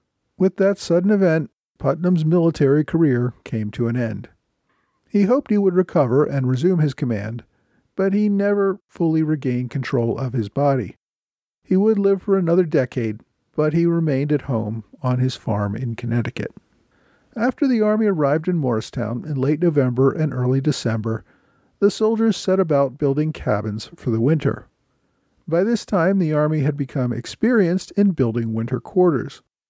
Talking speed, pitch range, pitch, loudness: 160 wpm, 120-185 Hz, 145 Hz, -20 LUFS